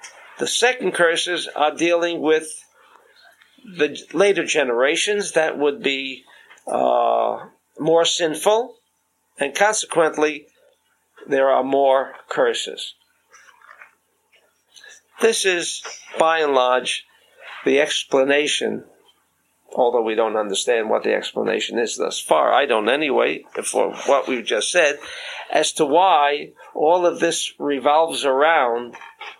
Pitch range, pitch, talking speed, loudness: 145-225 Hz, 165 Hz, 110 wpm, -19 LUFS